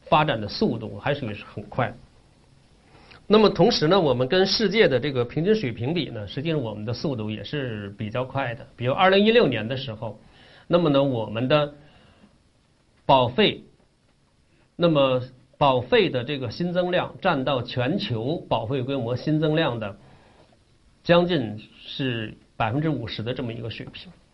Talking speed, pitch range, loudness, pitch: 245 characters per minute, 115-155 Hz, -23 LUFS, 135 Hz